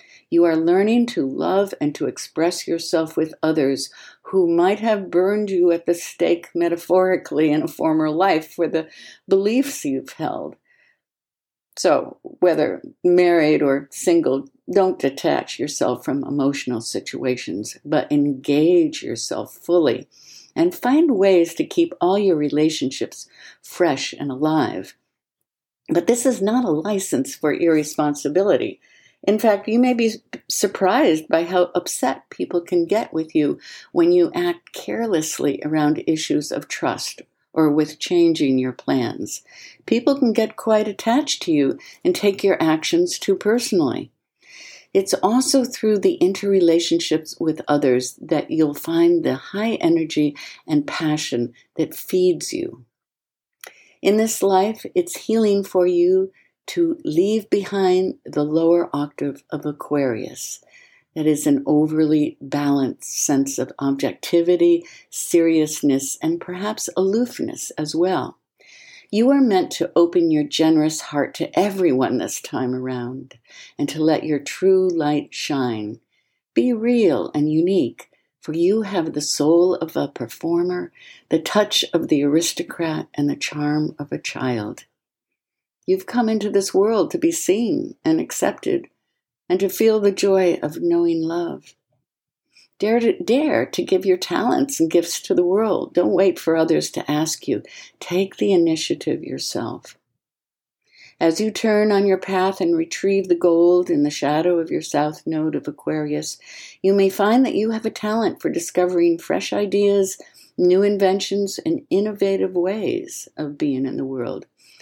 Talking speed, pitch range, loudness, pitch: 145 wpm, 155-230 Hz, -20 LUFS, 180 Hz